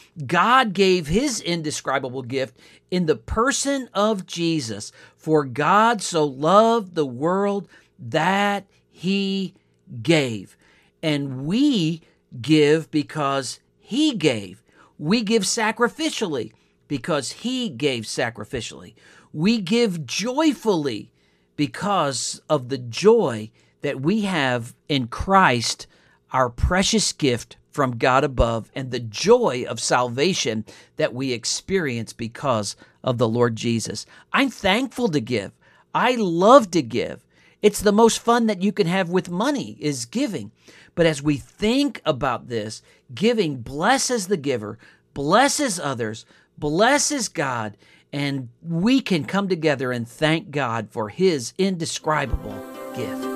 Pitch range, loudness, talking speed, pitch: 130-210 Hz, -22 LUFS, 125 wpm, 160 Hz